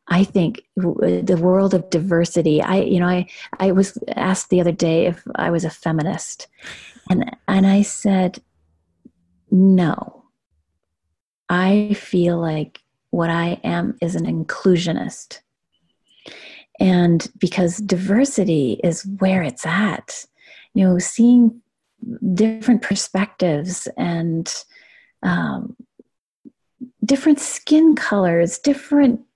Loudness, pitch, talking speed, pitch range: -18 LUFS, 185 Hz, 110 wpm, 170-215 Hz